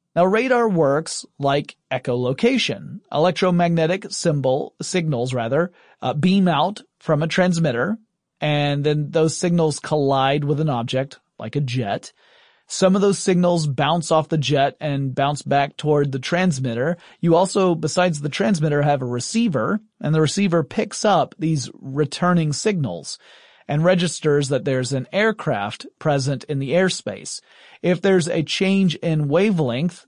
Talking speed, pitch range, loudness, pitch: 145 wpm, 145-185 Hz, -20 LUFS, 160 Hz